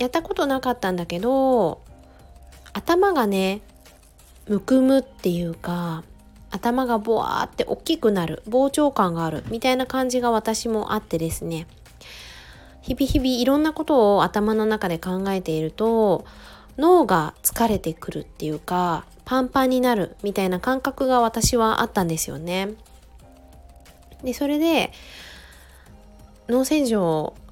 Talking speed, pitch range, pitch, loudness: 270 characters per minute, 170-260 Hz, 215 Hz, -22 LUFS